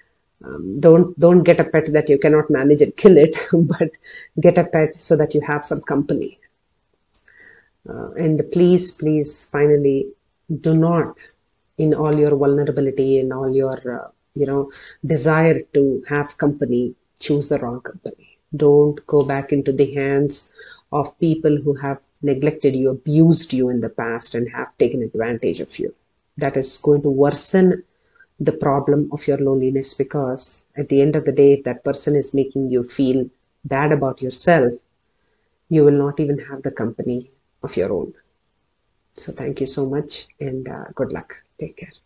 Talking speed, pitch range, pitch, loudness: 170 wpm, 135-155 Hz, 145 Hz, -18 LUFS